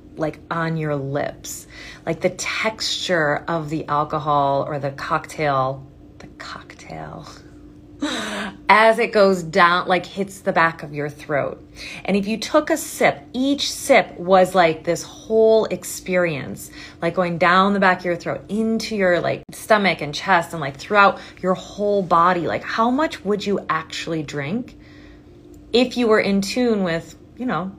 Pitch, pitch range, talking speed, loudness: 180 Hz, 160-205 Hz, 160 wpm, -20 LUFS